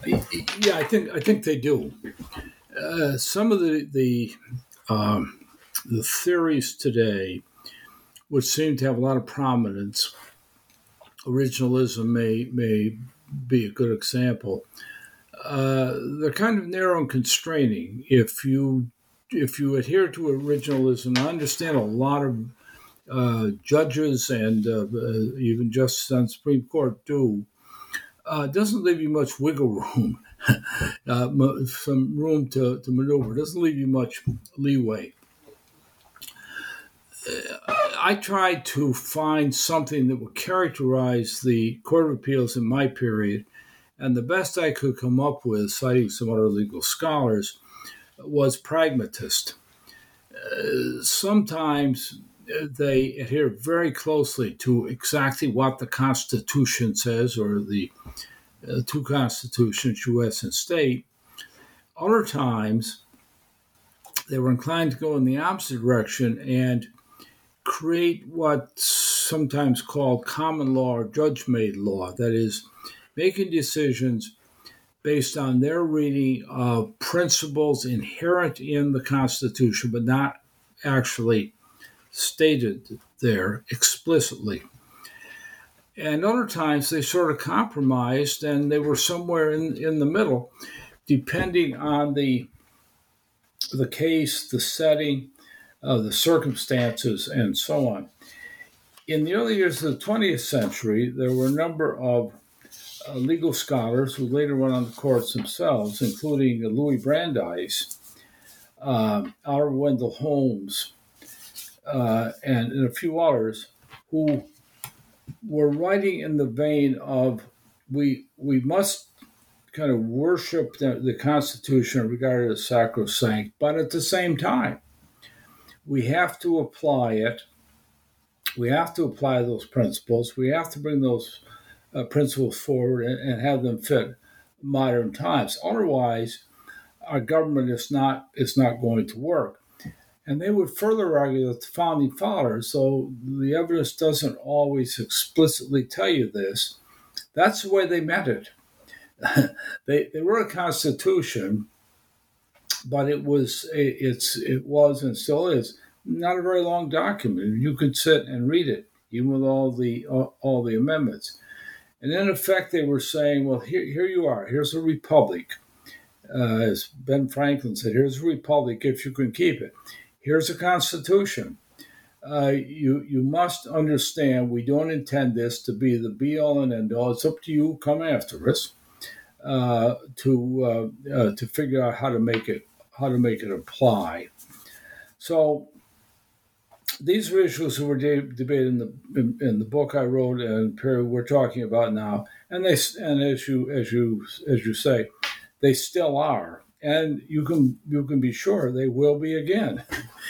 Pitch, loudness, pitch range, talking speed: 135 Hz, -24 LUFS, 125-155 Hz, 140 wpm